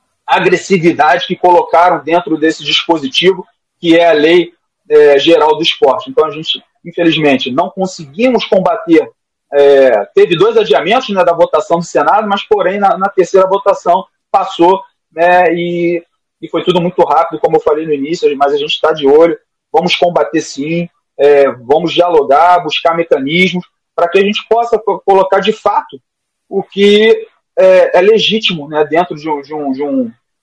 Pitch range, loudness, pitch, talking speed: 160-200 Hz, -10 LUFS, 175 Hz, 165 wpm